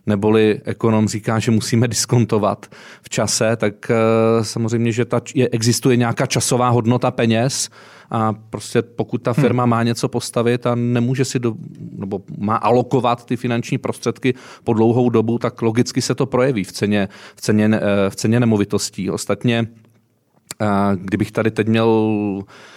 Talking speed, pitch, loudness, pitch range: 150 wpm, 115 Hz, -18 LUFS, 110-125 Hz